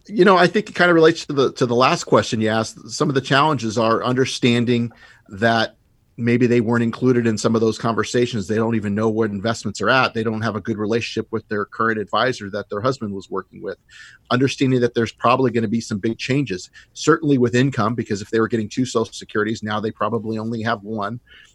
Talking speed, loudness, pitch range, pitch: 230 wpm, -19 LUFS, 110-125 Hz, 115 Hz